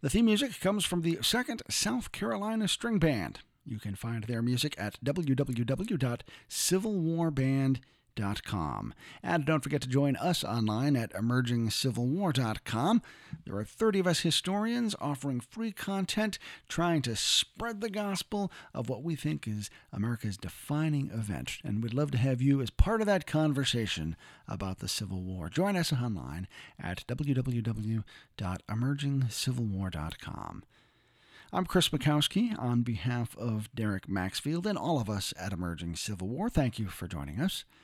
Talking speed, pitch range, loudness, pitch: 145 wpm, 110-170 Hz, -32 LUFS, 135 Hz